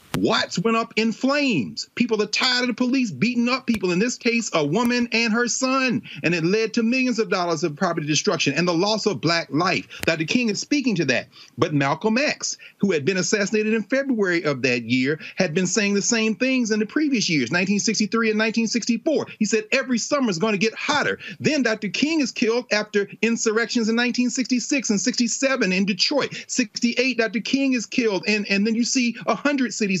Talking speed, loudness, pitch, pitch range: 205 wpm, -21 LUFS, 225 Hz, 200-245 Hz